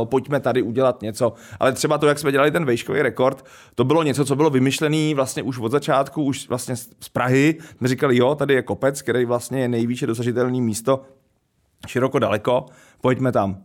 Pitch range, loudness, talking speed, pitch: 120-140 Hz, -21 LUFS, 195 wpm, 130 Hz